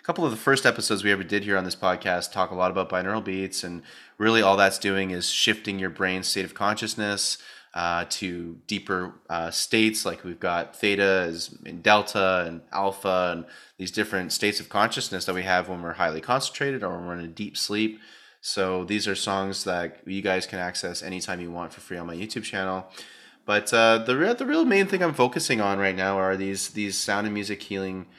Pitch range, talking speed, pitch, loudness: 90-105 Hz, 215 wpm, 95 Hz, -25 LUFS